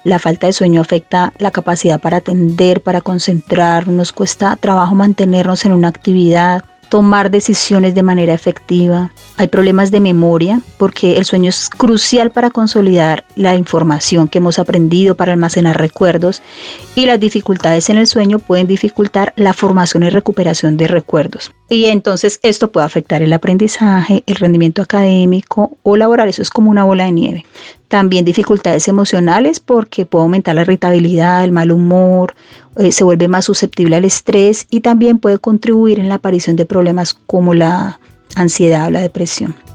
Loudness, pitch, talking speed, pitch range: -11 LUFS, 185 Hz, 165 wpm, 175-205 Hz